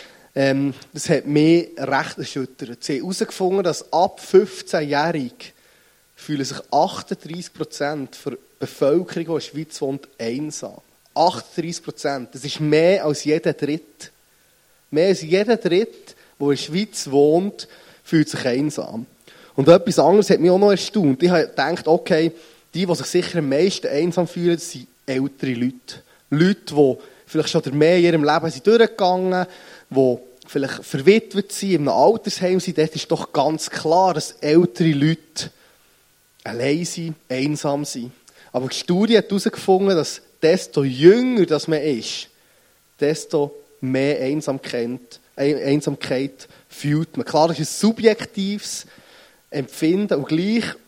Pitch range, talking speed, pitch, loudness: 145-180 Hz, 140 wpm, 160 Hz, -20 LUFS